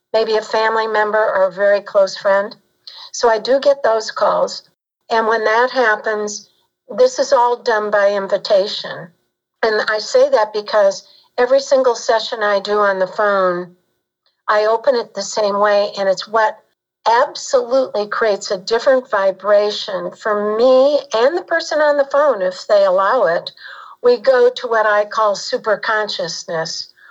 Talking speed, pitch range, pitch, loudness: 160 wpm, 205-260 Hz, 220 Hz, -16 LUFS